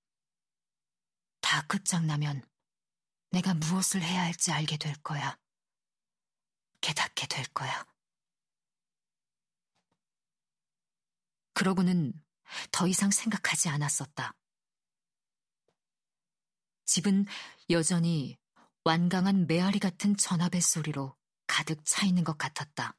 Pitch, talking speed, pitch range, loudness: 175 Hz, 180 characters per minute, 160-190 Hz, -29 LUFS